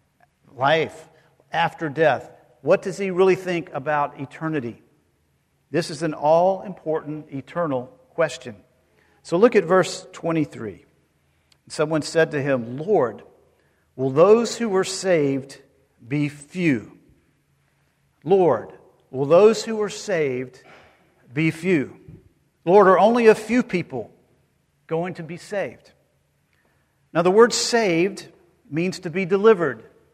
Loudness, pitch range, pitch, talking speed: -21 LUFS, 140-190 Hz, 165 Hz, 120 wpm